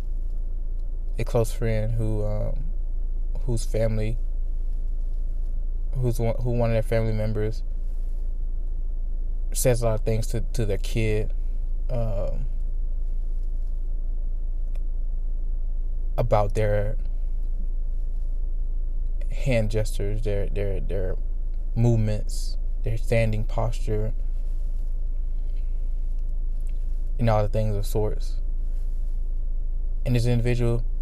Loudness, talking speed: -29 LUFS, 90 wpm